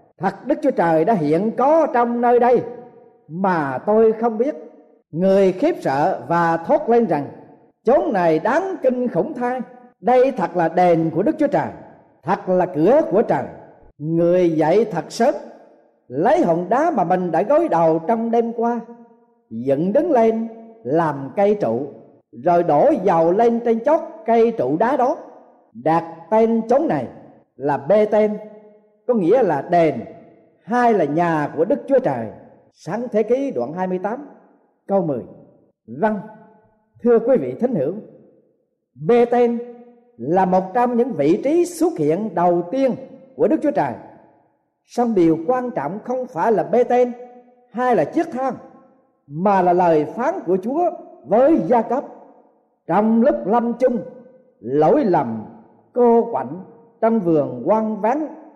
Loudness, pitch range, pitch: -18 LUFS, 180-250 Hz, 230 Hz